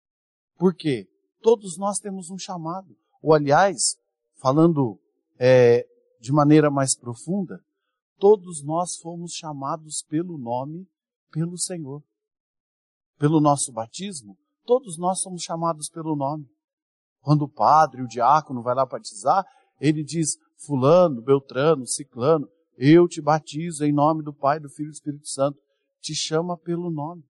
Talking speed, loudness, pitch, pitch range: 135 wpm, -22 LUFS, 155 Hz, 140-175 Hz